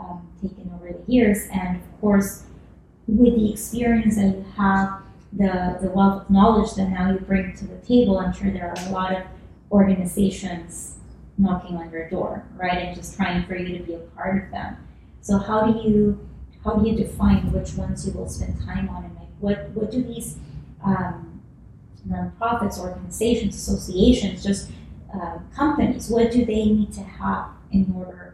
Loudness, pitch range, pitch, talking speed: -22 LUFS, 180-215 Hz, 195 Hz, 180 wpm